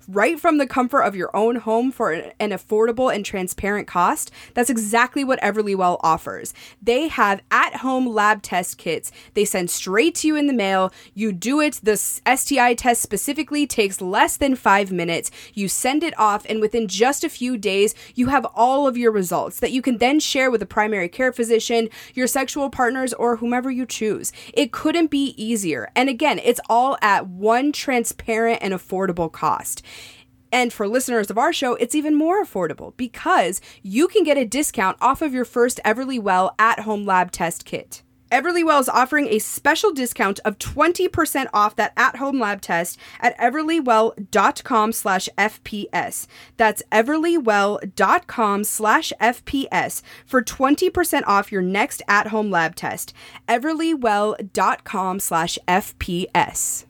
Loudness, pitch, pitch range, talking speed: -20 LUFS, 230 Hz, 205-265 Hz, 160 wpm